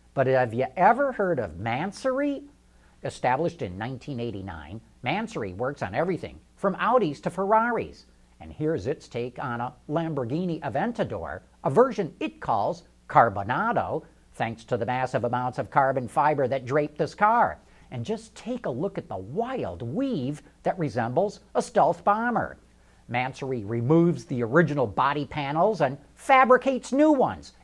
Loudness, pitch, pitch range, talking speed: -26 LUFS, 145 Hz, 120-195 Hz, 145 wpm